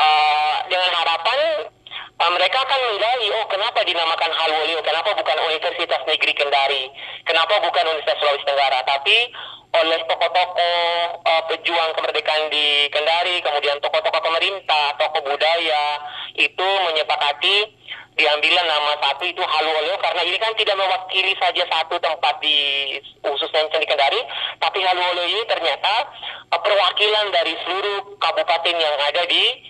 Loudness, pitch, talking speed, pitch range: -18 LUFS, 165 Hz, 130 wpm, 150-180 Hz